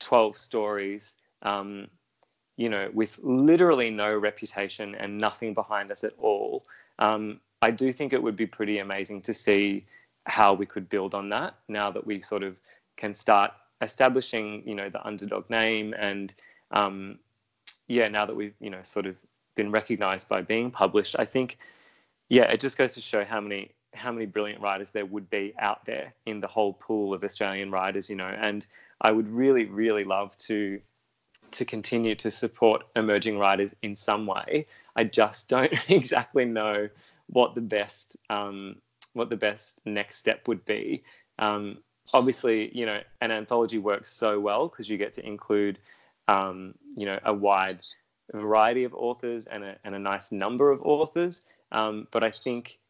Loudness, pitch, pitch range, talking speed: -27 LUFS, 105 Hz, 100-115 Hz, 175 wpm